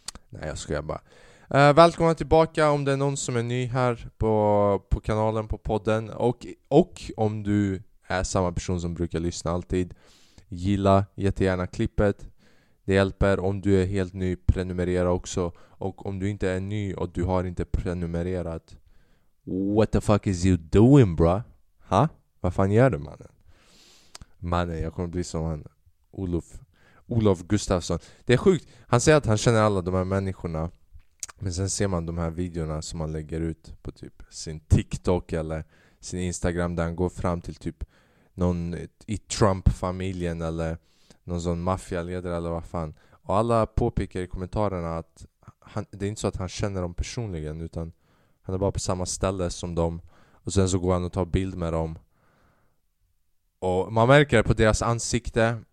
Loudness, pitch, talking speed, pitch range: -25 LUFS, 95 Hz, 175 wpm, 85-105 Hz